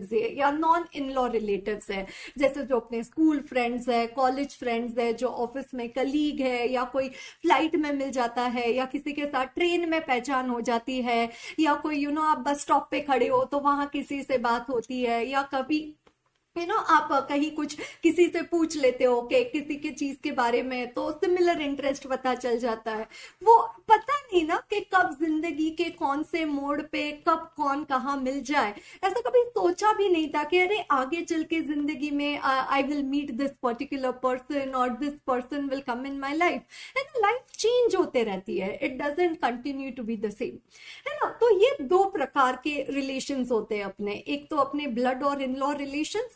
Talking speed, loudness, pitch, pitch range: 200 wpm, -27 LUFS, 280 Hz, 255-315 Hz